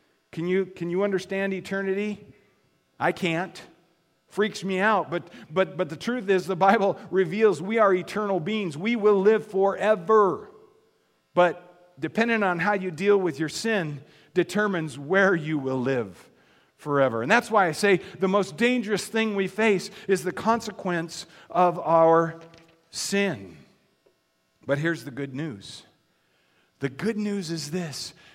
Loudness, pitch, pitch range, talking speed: -25 LUFS, 185 Hz, 165-205 Hz, 150 wpm